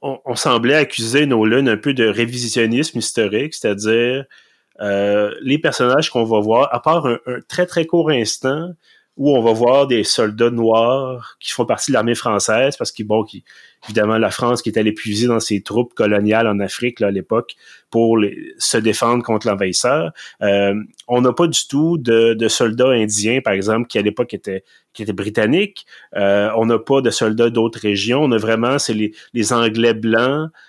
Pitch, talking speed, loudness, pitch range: 115 Hz, 195 wpm, -17 LUFS, 110-125 Hz